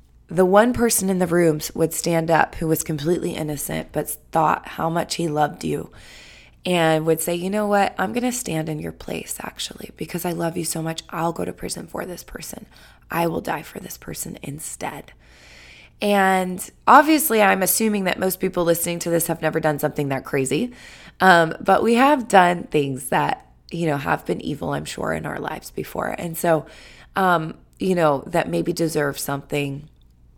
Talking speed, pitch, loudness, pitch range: 190 wpm, 170 Hz, -21 LUFS, 155-185 Hz